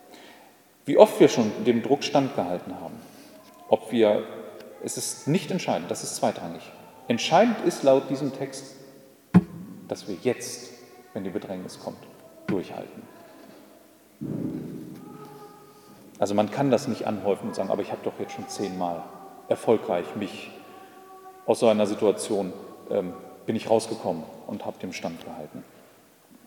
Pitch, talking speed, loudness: 135 Hz, 135 wpm, -26 LUFS